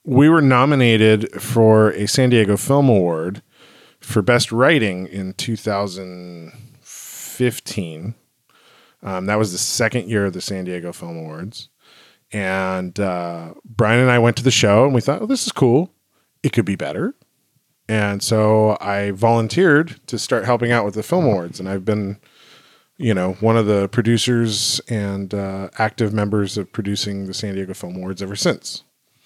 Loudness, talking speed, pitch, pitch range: -18 LUFS, 165 wpm, 105 Hz, 95-120 Hz